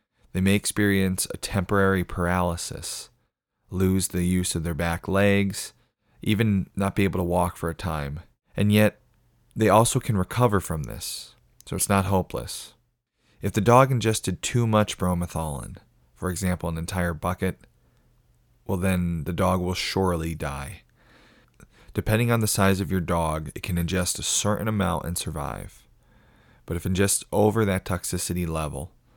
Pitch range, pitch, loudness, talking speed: 90-105 Hz, 95 Hz, -25 LUFS, 155 wpm